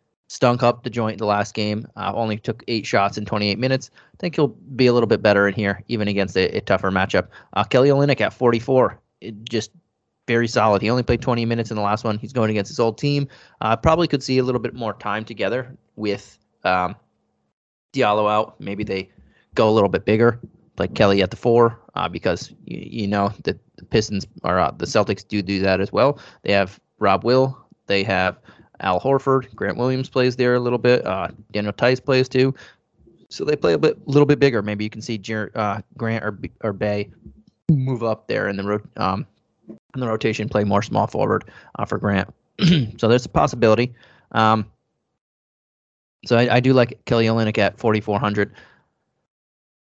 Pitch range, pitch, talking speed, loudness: 105-125 Hz, 110 Hz, 205 wpm, -20 LUFS